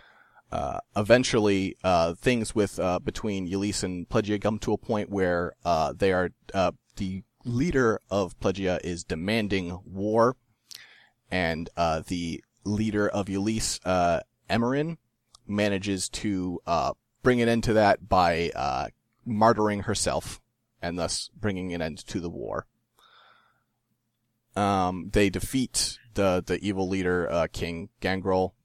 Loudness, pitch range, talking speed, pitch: -27 LUFS, 90-110 Hz, 135 wpm, 100 Hz